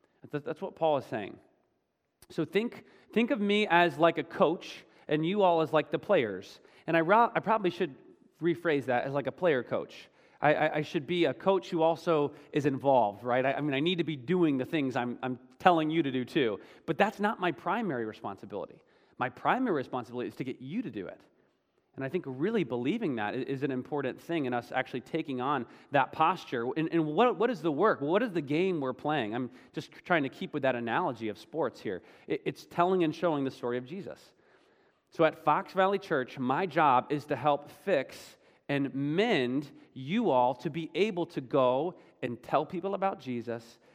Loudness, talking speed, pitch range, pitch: -30 LUFS, 205 wpm, 130-180 Hz, 155 Hz